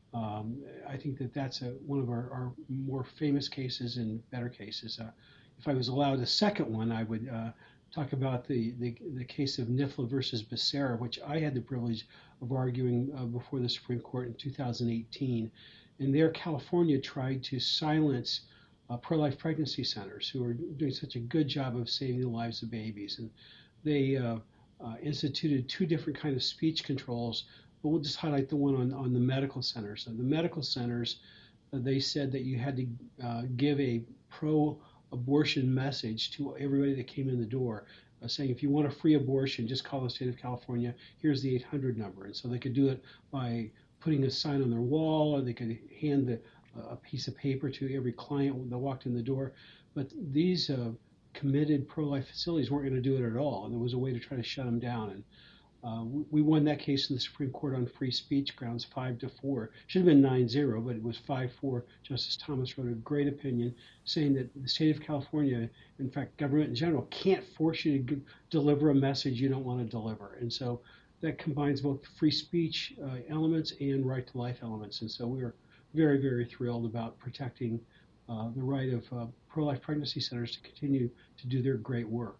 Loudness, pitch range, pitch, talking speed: -33 LUFS, 120-145 Hz, 130 Hz, 205 wpm